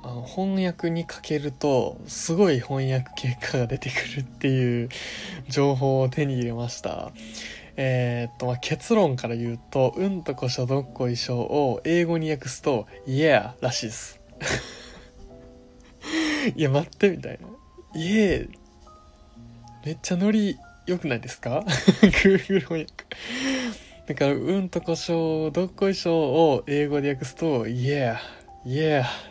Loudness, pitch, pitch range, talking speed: -25 LUFS, 140 Hz, 125-170 Hz, 275 characters per minute